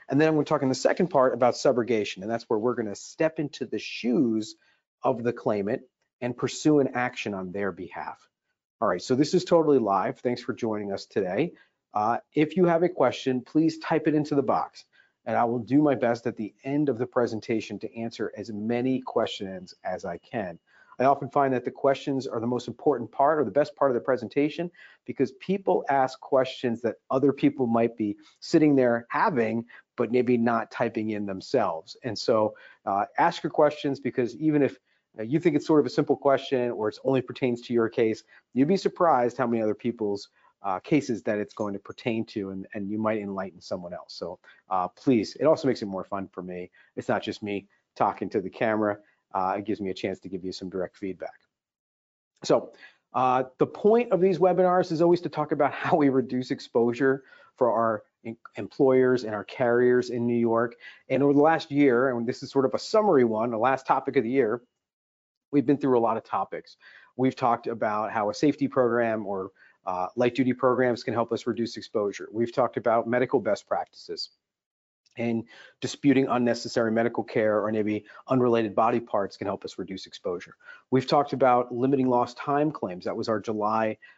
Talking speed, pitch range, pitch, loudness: 205 wpm, 110-140 Hz, 125 Hz, -26 LUFS